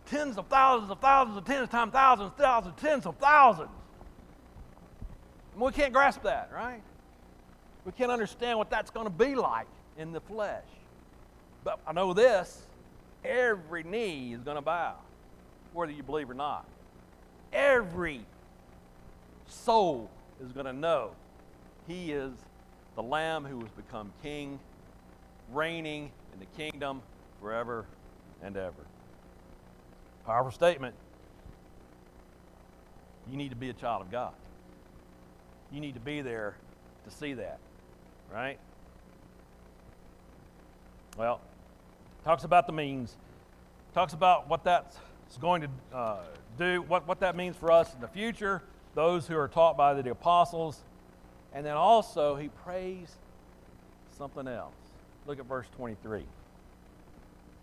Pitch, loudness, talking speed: 115 Hz, -30 LUFS, 130 wpm